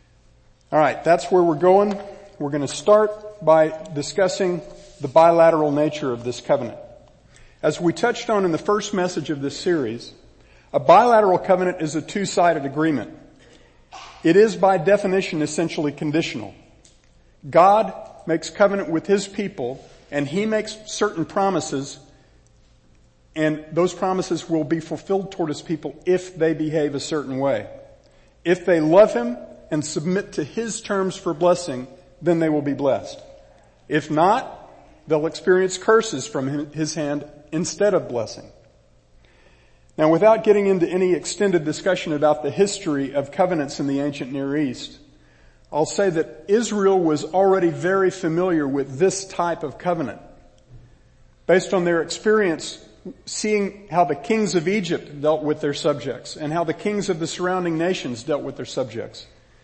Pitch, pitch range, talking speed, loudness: 165 Hz, 150-190 Hz, 150 wpm, -21 LUFS